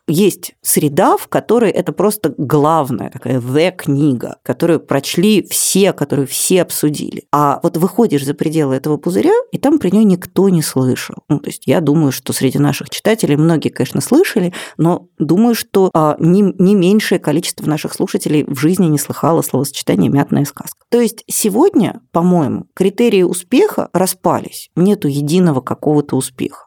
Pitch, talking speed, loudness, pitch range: 165 Hz, 155 wpm, -14 LUFS, 145-195 Hz